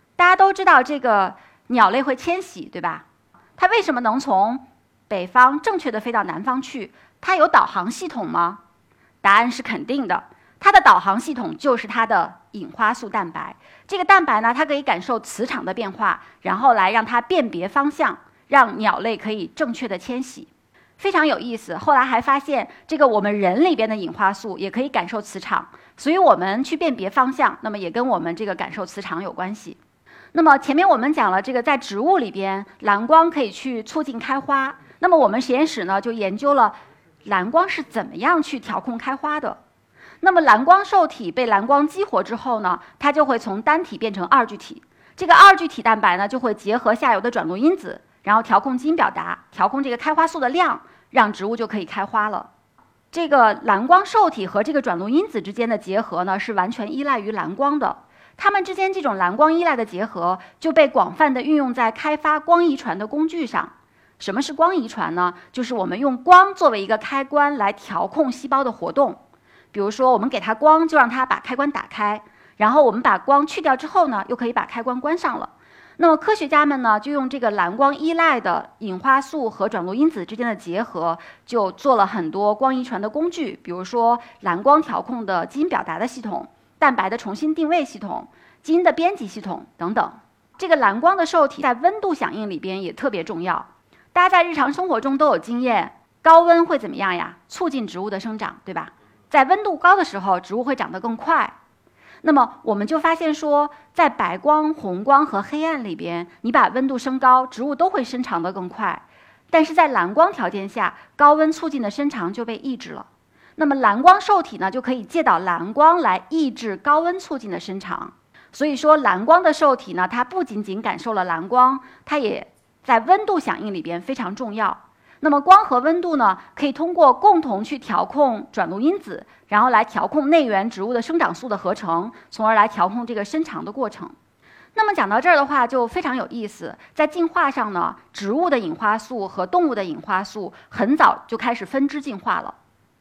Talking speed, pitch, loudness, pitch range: 300 characters per minute, 260 Hz, -19 LUFS, 215-315 Hz